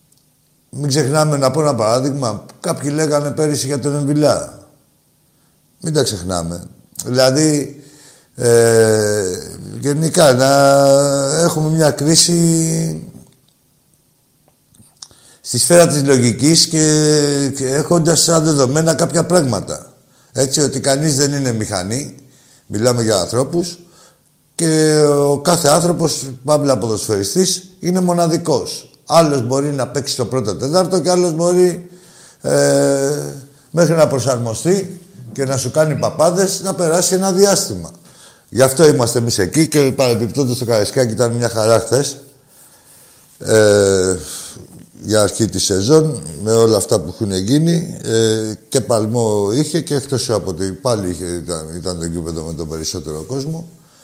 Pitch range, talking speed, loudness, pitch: 120-160 Hz, 130 wpm, -15 LUFS, 140 Hz